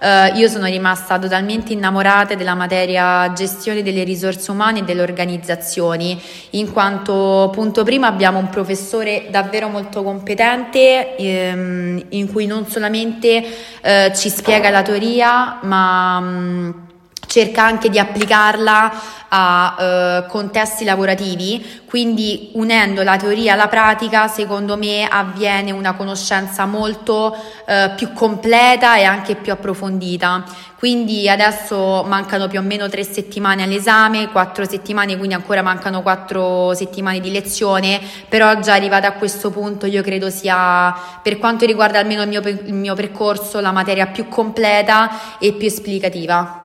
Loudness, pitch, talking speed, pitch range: -15 LUFS, 200 Hz, 140 wpm, 190-215 Hz